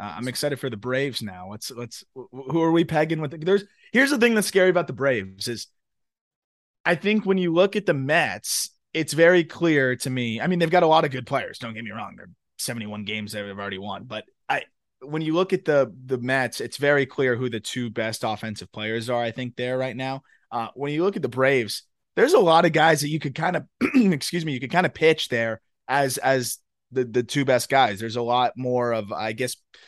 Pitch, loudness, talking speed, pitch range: 130 Hz, -23 LUFS, 240 wpm, 120-160 Hz